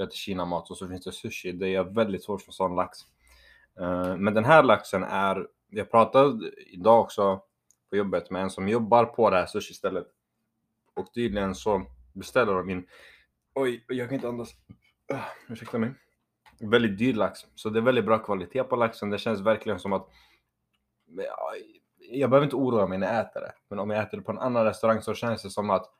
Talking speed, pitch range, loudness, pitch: 200 wpm, 95-115 Hz, -26 LUFS, 100 Hz